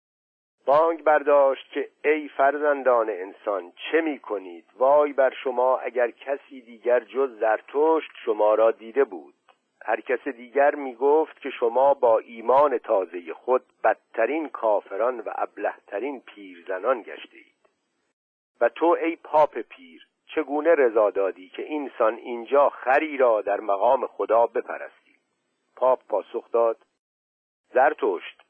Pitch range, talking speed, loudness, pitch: 120-160 Hz, 125 wpm, -23 LUFS, 140 Hz